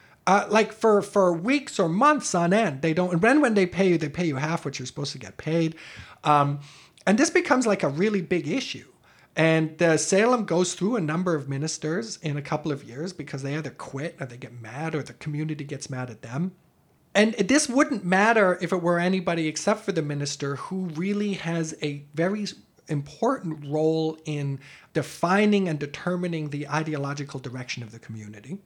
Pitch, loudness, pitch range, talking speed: 160 Hz, -25 LUFS, 145-190 Hz, 195 wpm